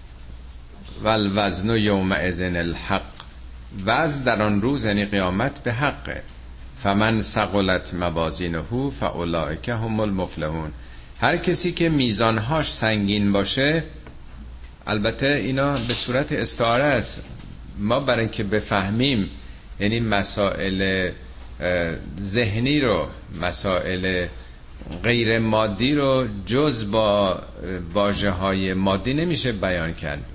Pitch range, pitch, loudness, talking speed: 85-115 Hz, 100 Hz, -22 LUFS, 105 wpm